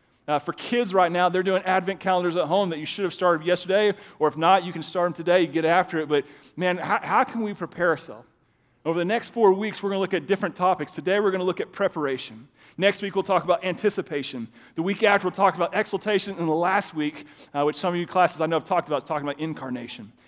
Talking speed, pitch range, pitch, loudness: 260 wpm, 155-195 Hz, 180 Hz, -24 LUFS